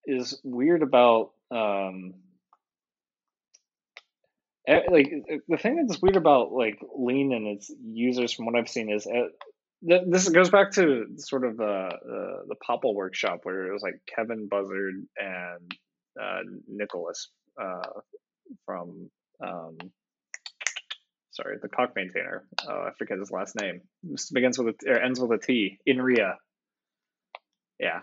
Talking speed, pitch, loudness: 145 wpm, 125 Hz, -26 LUFS